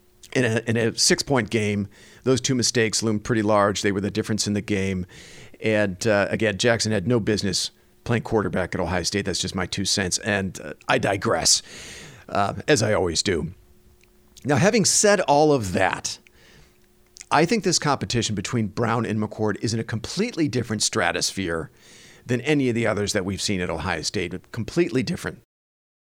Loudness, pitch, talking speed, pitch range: -22 LUFS, 105 Hz, 185 wpm, 95-120 Hz